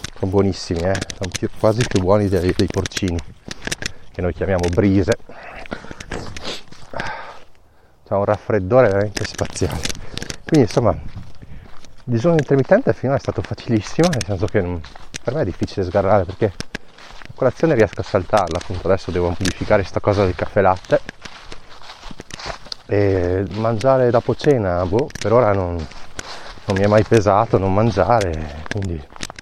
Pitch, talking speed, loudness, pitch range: 100 Hz, 145 wpm, -19 LUFS, 95-115 Hz